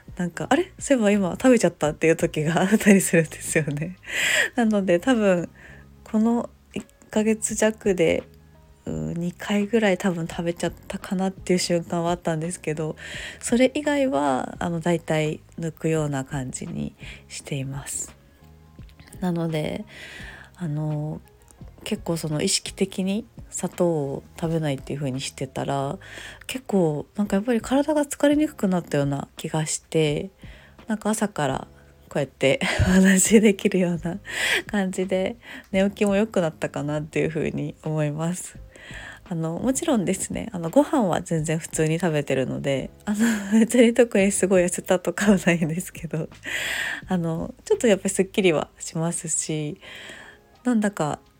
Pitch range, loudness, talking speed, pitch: 155-205 Hz, -23 LUFS, 315 characters per minute, 175 Hz